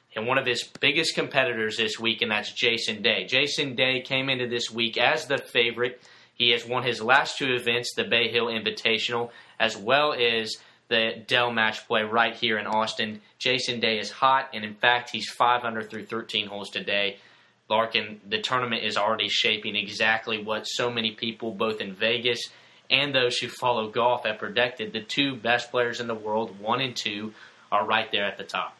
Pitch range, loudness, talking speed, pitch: 110-125 Hz, -25 LUFS, 195 wpm, 115 Hz